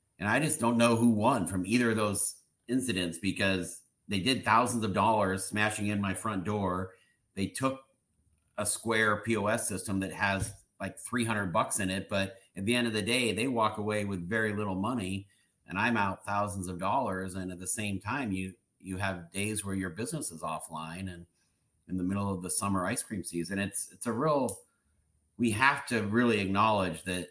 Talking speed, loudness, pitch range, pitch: 200 wpm, -31 LUFS, 95-110 Hz, 100 Hz